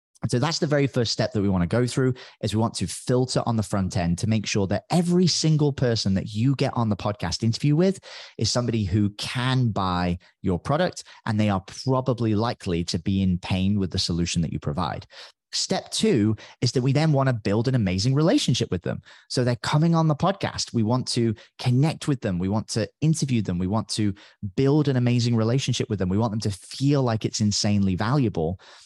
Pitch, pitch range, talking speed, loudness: 115 Hz, 100-130 Hz, 225 wpm, -24 LUFS